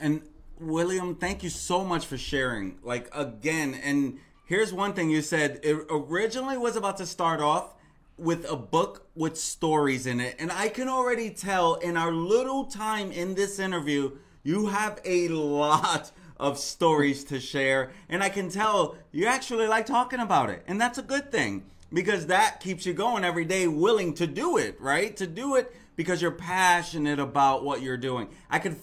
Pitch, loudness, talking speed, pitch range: 175 Hz, -27 LUFS, 185 wpm, 150-205 Hz